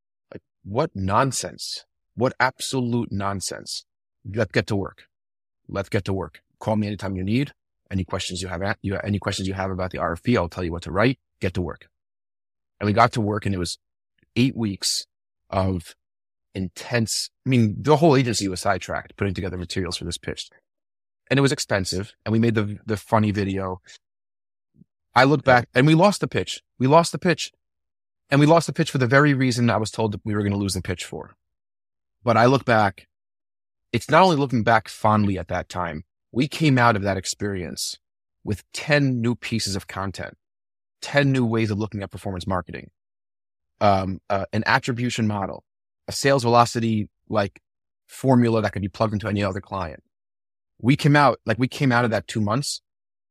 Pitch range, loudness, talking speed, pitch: 95-120 Hz, -22 LUFS, 195 wpm, 105 Hz